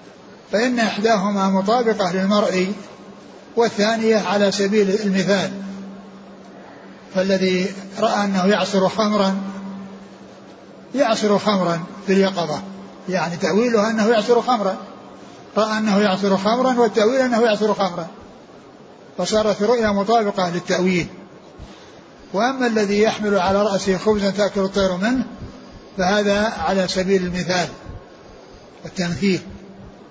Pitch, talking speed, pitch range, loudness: 200 Hz, 100 wpm, 190-215 Hz, -19 LUFS